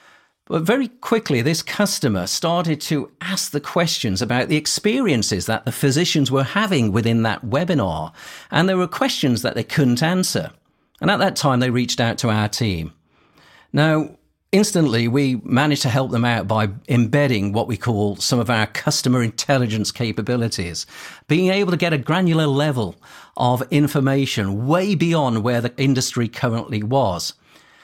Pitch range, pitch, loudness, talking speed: 115-160 Hz, 135 Hz, -19 LUFS, 160 wpm